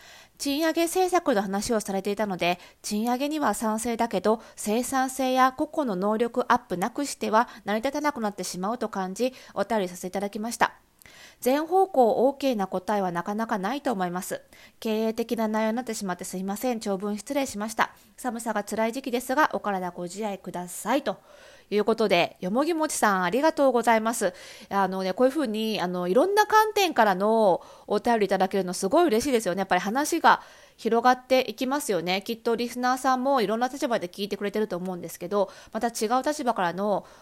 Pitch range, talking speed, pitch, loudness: 195-260 Hz, 415 characters per minute, 225 Hz, -26 LUFS